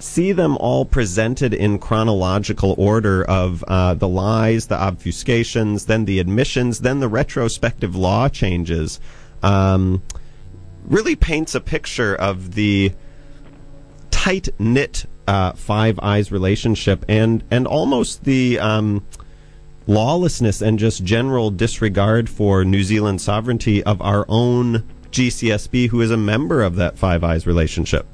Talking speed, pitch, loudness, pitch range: 130 wpm, 110 Hz, -18 LUFS, 95-125 Hz